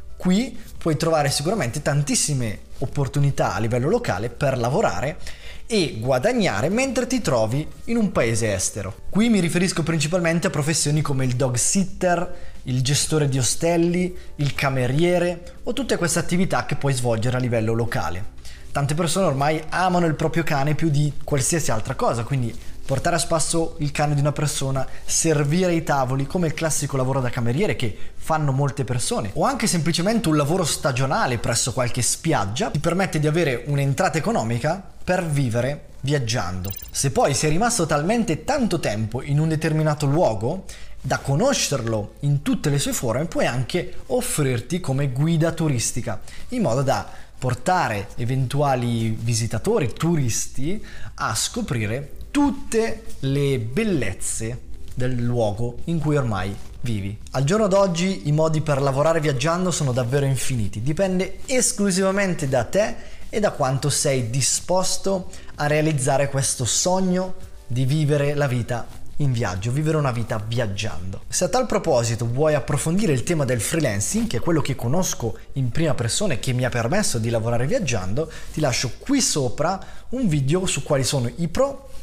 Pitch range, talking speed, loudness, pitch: 125-170 Hz, 155 wpm, -22 LUFS, 145 Hz